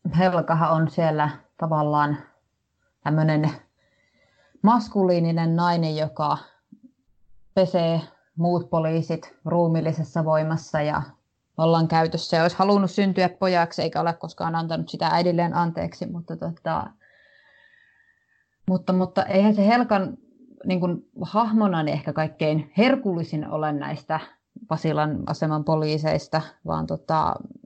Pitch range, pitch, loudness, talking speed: 155-190 Hz, 165 Hz, -23 LUFS, 105 wpm